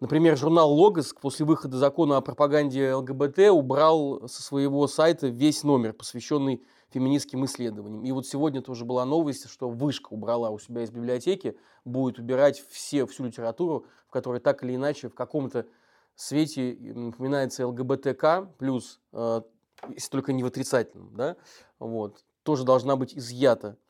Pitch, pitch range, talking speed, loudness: 135 Hz, 125-145 Hz, 145 wpm, -26 LUFS